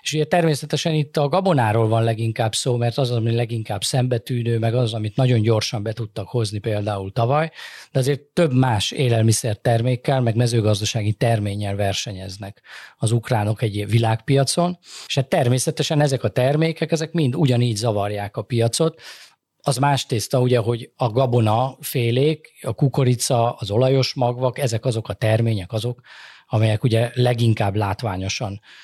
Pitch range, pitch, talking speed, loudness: 110-135 Hz, 120 Hz, 150 wpm, -21 LUFS